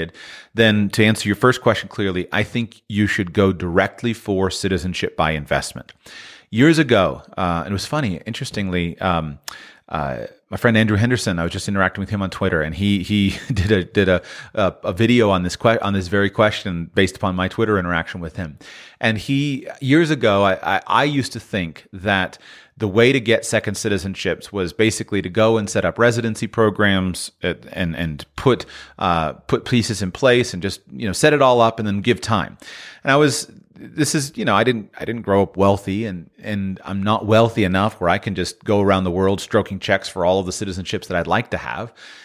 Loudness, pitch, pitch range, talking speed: -19 LUFS, 100 Hz, 95-115 Hz, 210 wpm